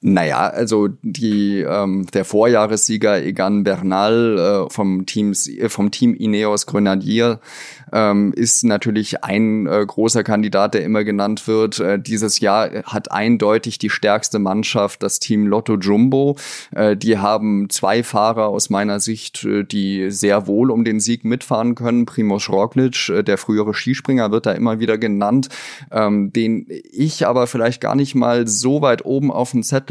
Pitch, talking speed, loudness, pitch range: 110 Hz, 160 wpm, -17 LUFS, 100-120 Hz